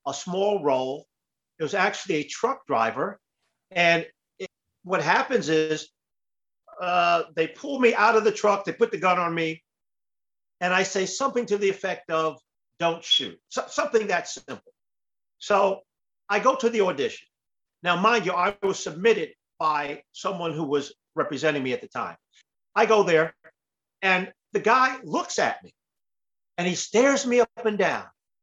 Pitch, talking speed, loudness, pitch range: 185 Hz, 165 wpm, -24 LUFS, 160-235 Hz